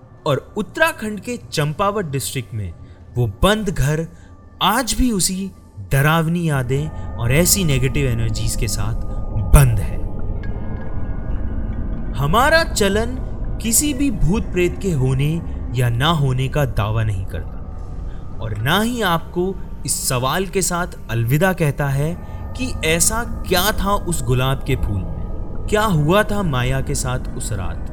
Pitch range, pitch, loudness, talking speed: 105-175 Hz, 130 Hz, -19 LUFS, 140 wpm